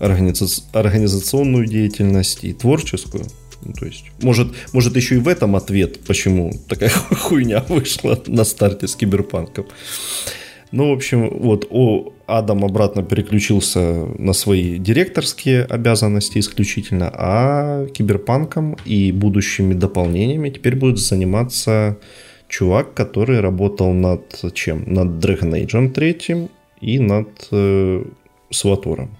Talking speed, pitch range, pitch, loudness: 115 wpm, 95-125 Hz, 105 Hz, -17 LUFS